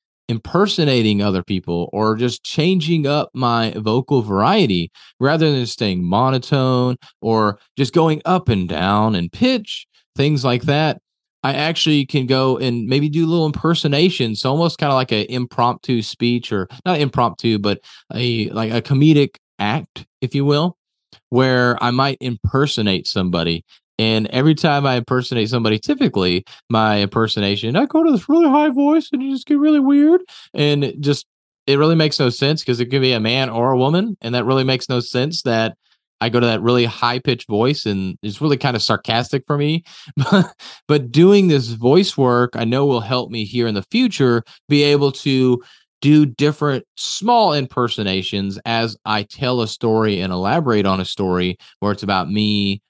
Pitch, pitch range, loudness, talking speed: 125 Hz, 110-150 Hz, -17 LUFS, 180 wpm